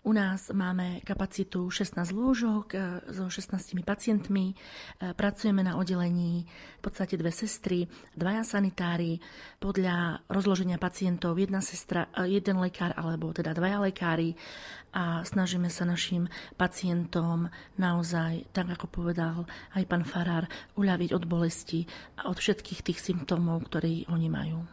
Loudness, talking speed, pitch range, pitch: -31 LUFS, 125 wpm, 170-195 Hz, 180 Hz